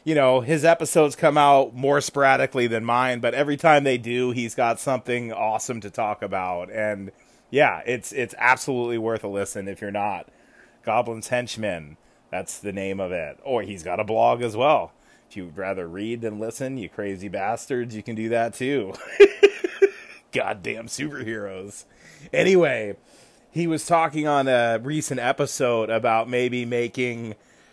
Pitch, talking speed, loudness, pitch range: 120 Hz, 160 wpm, -23 LUFS, 110-140 Hz